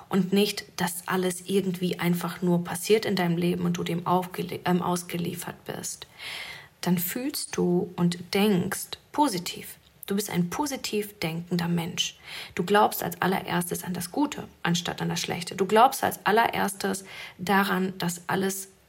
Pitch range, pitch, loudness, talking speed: 175-200 Hz, 180 Hz, -27 LUFS, 155 wpm